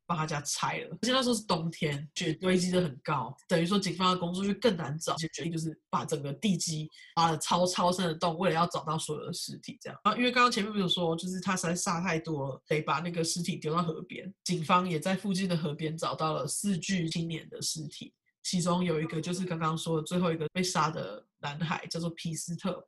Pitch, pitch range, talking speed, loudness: 170 Hz, 160-185 Hz, 350 characters per minute, -31 LUFS